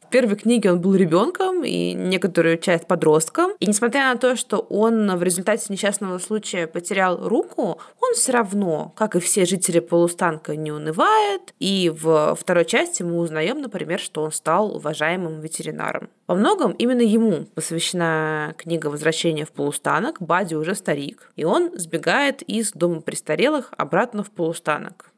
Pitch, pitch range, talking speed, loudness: 180 Hz, 165-215 Hz, 155 wpm, -21 LUFS